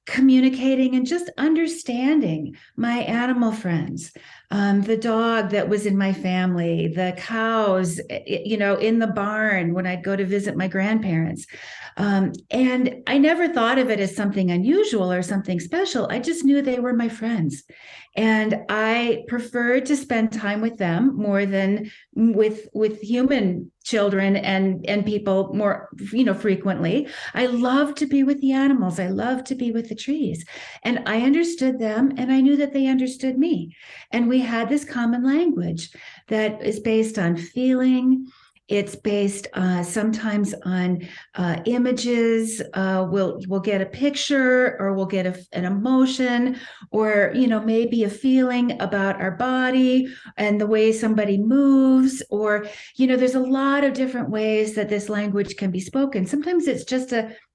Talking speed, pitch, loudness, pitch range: 165 wpm, 225 Hz, -21 LUFS, 200-255 Hz